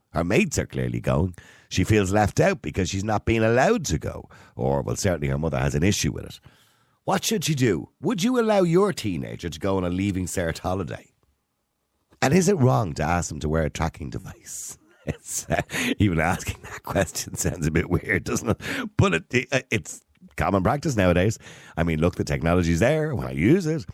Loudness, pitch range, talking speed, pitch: -24 LUFS, 80-130 Hz, 210 wpm, 95 Hz